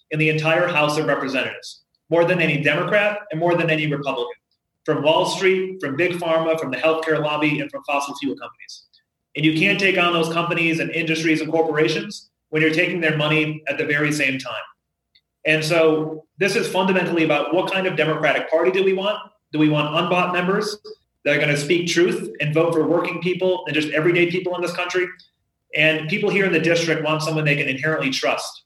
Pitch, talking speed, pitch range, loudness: 160 Hz, 205 wpm, 155-180 Hz, -20 LUFS